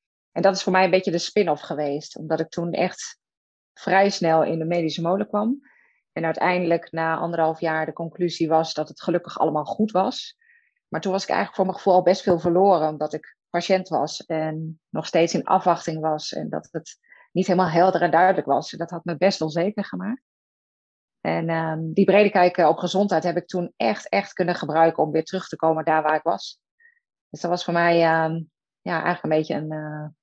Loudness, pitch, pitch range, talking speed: -22 LUFS, 170 Hz, 160-190 Hz, 215 wpm